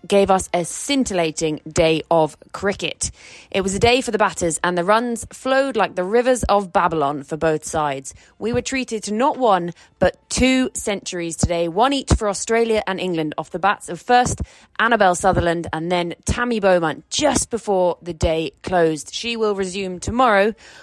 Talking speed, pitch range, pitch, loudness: 180 wpm, 170-230 Hz, 190 Hz, -20 LUFS